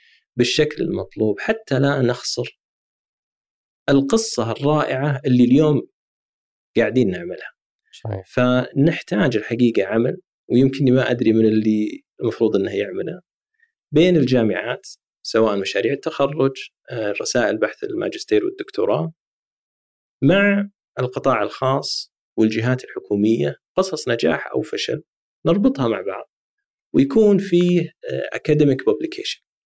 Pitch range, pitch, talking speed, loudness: 120-200 Hz, 140 Hz, 95 wpm, -20 LUFS